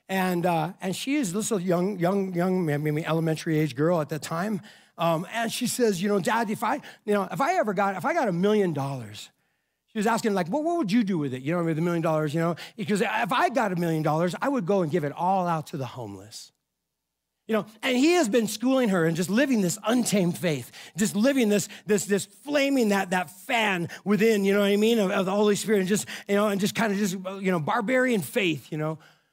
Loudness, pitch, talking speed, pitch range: -25 LUFS, 195 Hz, 255 wpm, 170-220 Hz